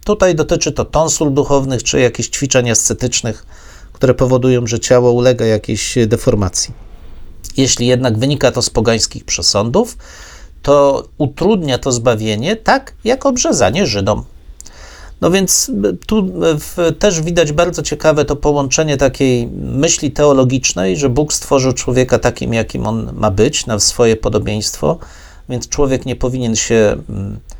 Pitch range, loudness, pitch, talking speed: 115-150 Hz, -14 LUFS, 130 Hz, 130 wpm